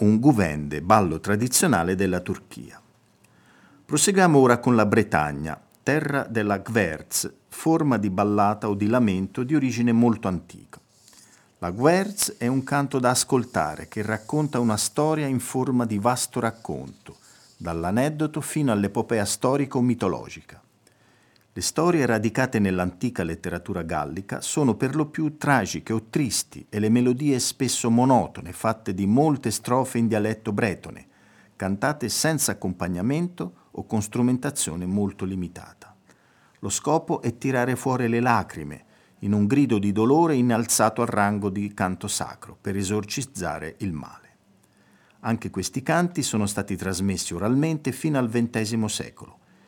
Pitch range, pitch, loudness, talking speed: 100-130 Hz, 115 Hz, -24 LUFS, 135 wpm